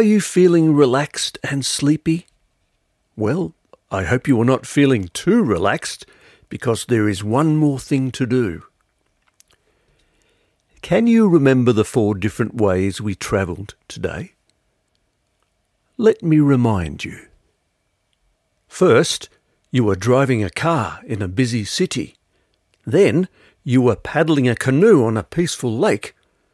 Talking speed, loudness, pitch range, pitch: 130 wpm, -18 LUFS, 105-150 Hz, 130 Hz